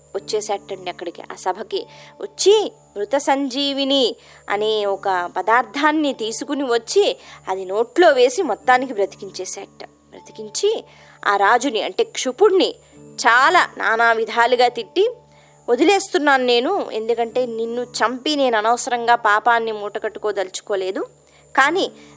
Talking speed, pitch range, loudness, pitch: 95 wpm, 205-290 Hz, -19 LUFS, 235 Hz